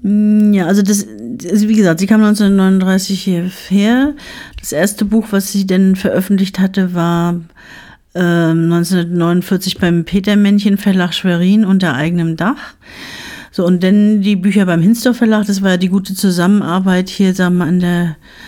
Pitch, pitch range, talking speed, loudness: 190 Hz, 180-205 Hz, 150 wpm, -13 LUFS